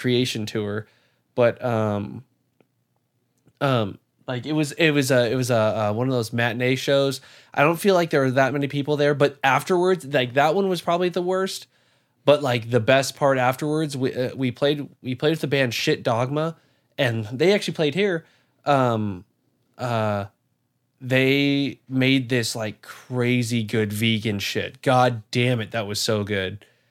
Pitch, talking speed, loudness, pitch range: 130 Hz, 175 wpm, -22 LUFS, 120-145 Hz